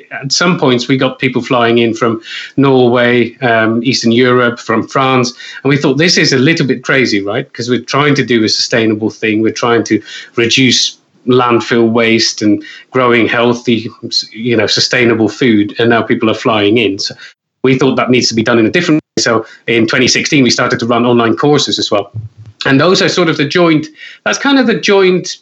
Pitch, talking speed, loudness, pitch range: 120 Hz, 205 wpm, -11 LUFS, 115-135 Hz